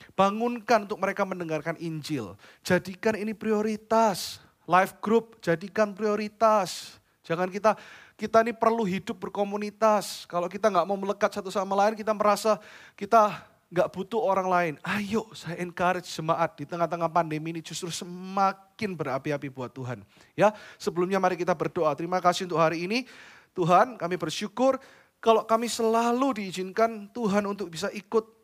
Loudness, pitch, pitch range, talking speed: -27 LUFS, 200 Hz, 175-215 Hz, 145 wpm